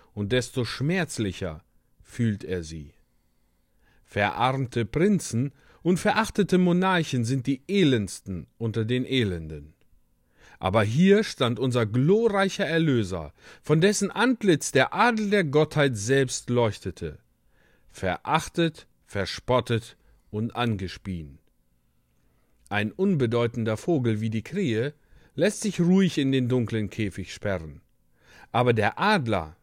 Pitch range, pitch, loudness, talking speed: 95-155 Hz, 120 Hz, -25 LUFS, 105 wpm